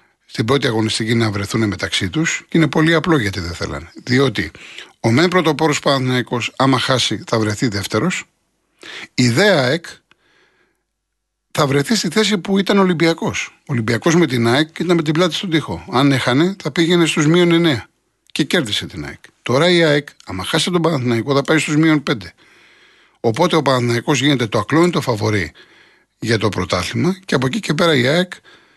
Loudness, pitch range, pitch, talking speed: -16 LUFS, 115-165 Hz, 140 Hz, 175 wpm